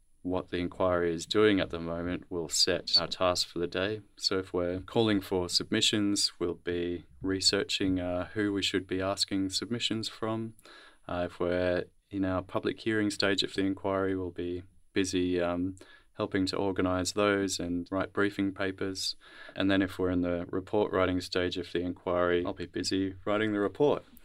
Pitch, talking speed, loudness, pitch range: 95 Hz, 180 wpm, -30 LUFS, 90-100 Hz